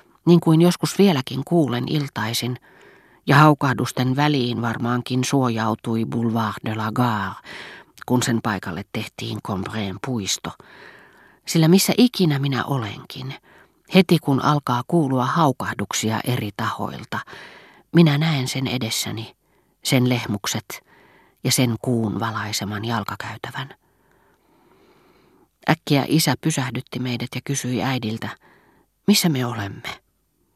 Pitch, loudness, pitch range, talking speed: 125 Hz, -21 LUFS, 115-145 Hz, 105 wpm